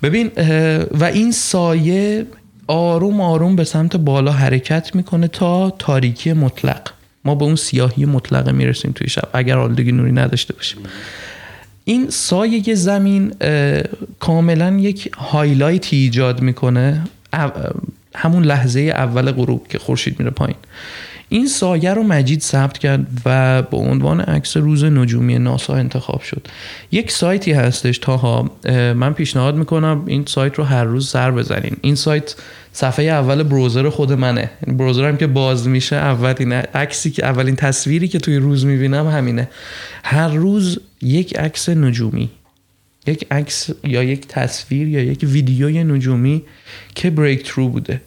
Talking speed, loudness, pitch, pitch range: 140 wpm, -16 LUFS, 140 Hz, 130-160 Hz